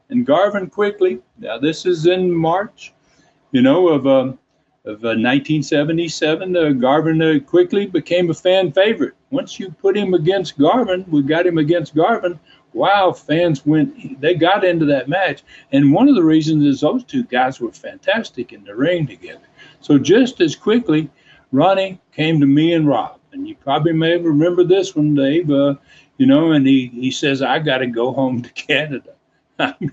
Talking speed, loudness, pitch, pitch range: 175 wpm, -16 LUFS, 170 Hz, 150-195 Hz